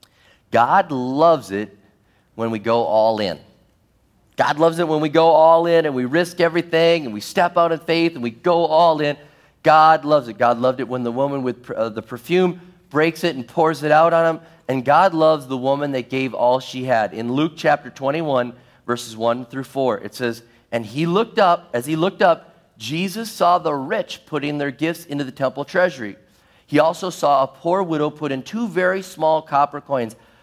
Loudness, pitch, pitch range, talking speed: -19 LUFS, 145 Hz, 125-165 Hz, 205 wpm